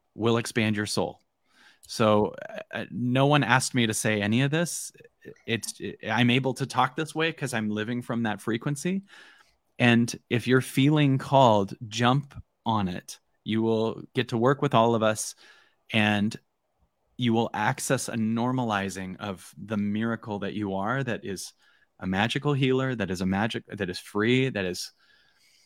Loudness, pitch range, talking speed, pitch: -26 LUFS, 105-130 Hz, 170 wpm, 115 Hz